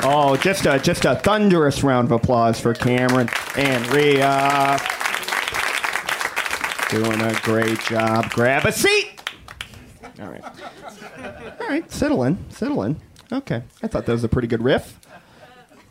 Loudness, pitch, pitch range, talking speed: -19 LUFS, 130 Hz, 115-145 Hz, 140 wpm